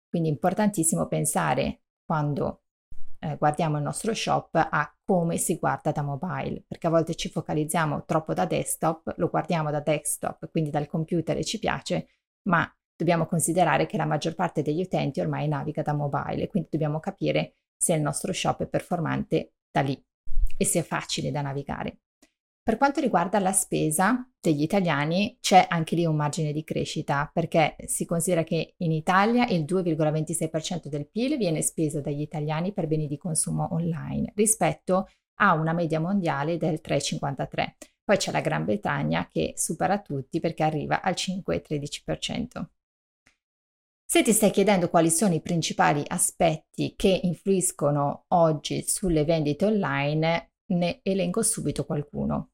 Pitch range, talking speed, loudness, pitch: 150-185 Hz, 155 wpm, -26 LUFS, 165 Hz